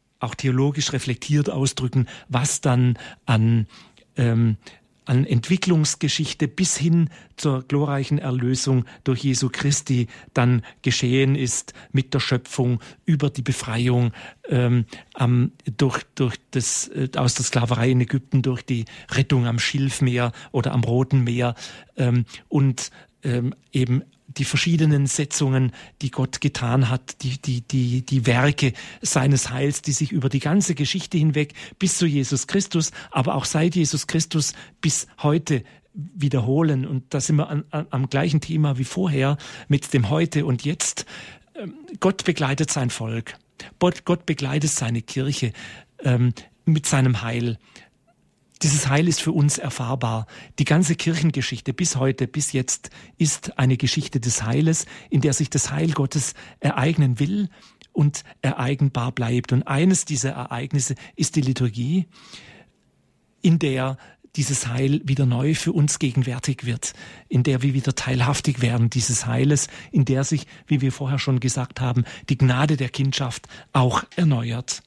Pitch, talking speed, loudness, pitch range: 135 Hz, 145 wpm, -22 LUFS, 125-150 Hz